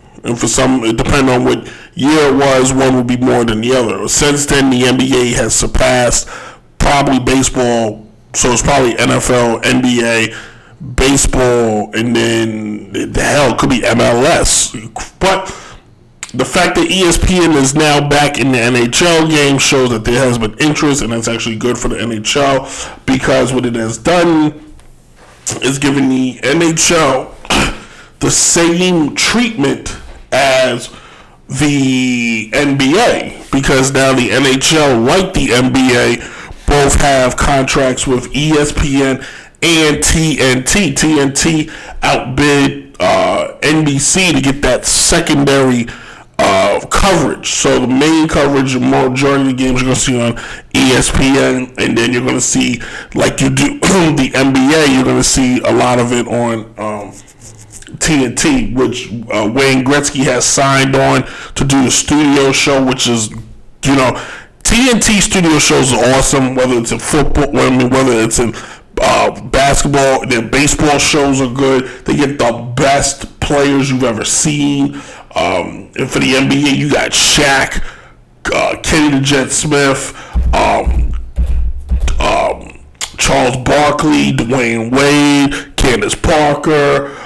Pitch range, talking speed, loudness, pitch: 120-145 Hz, 140 wpm, -11 LUFS, 135 Hz